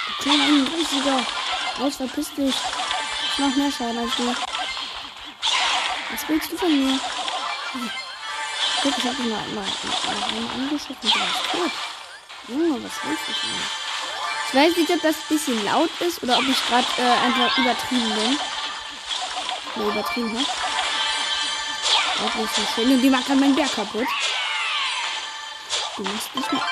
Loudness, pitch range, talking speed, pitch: -22 LUFS, 245-295 Hz, 155 wpm, 265 Hz